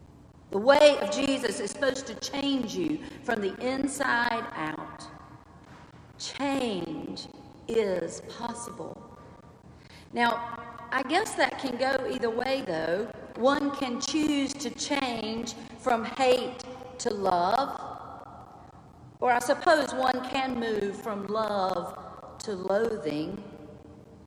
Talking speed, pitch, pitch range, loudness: 110 wpm, 245 Hz, 225-270 Hz, -28 LUFS